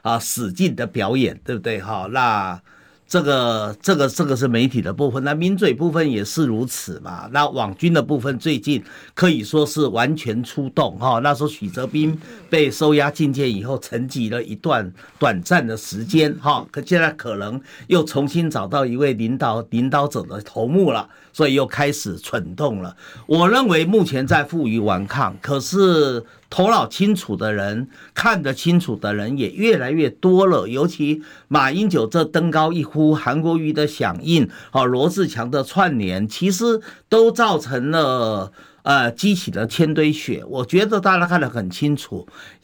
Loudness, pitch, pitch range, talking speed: -19 LUFS, 145 Hz, 120-165 Hz, 260 characters per minute